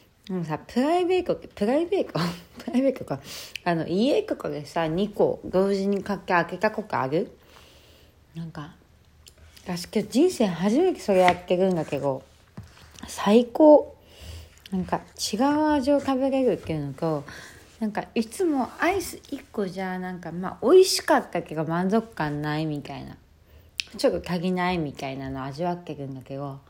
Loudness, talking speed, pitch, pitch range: -25 LUFS, 310 characters per minute, 180 Hz, 150-240 Hz